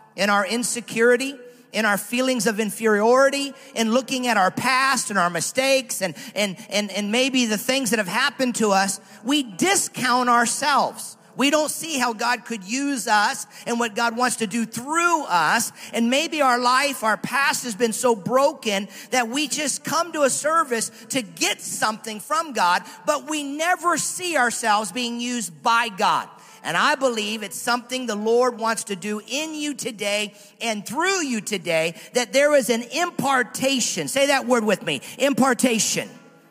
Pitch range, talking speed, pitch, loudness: 215-270 Hz, 175 wpm, 240 Hz, -21 LUFS